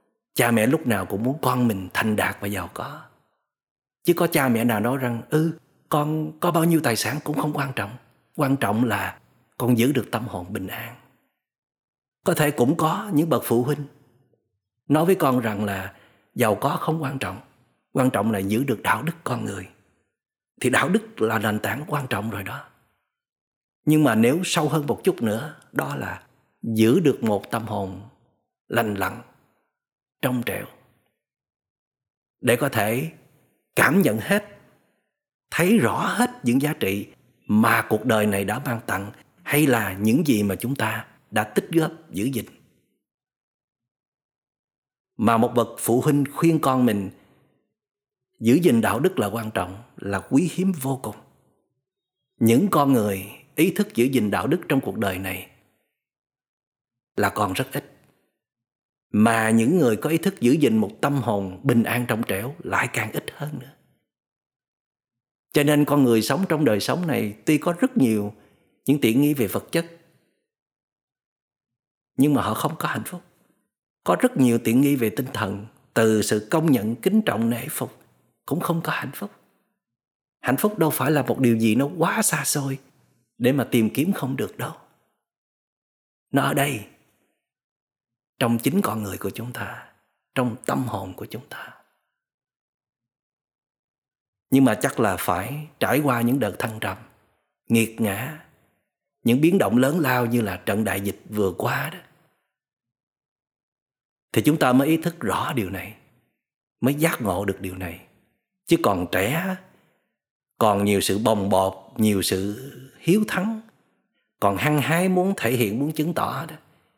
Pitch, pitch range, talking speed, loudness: 125 Hz, 110-150 Hz, 170 wpm, -23 LUFS